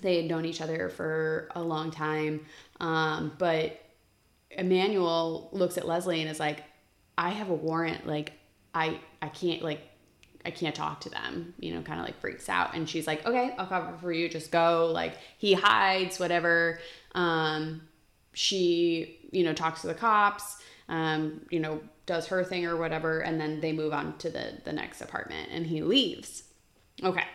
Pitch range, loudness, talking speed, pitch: 155-175 Hz, -30 LUFS, 180 wpm, 165 Hz